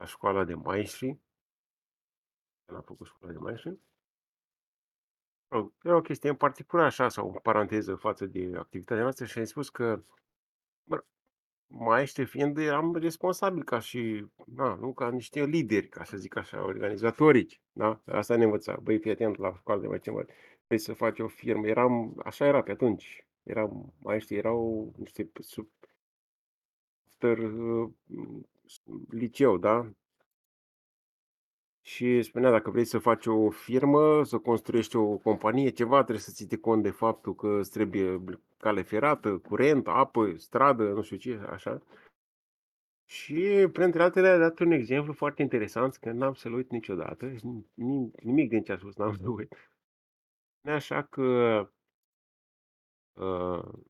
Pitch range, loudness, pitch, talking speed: 110-135 Hz, -28 LUFS, 115 Hz, 145 wpm